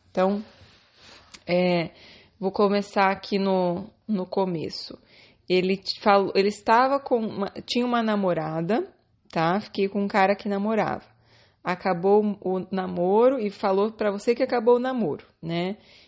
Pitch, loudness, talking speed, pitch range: 195 Hz, -24 LUFS, 135 wpm, 180-210 Hz